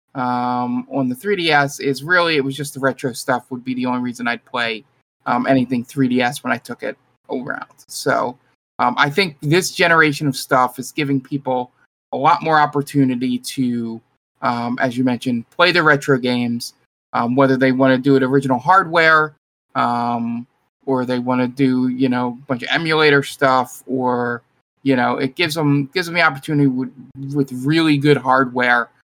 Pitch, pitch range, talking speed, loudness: 130 Hz, 125-145 Hz, 180 wpm, -18 LUFS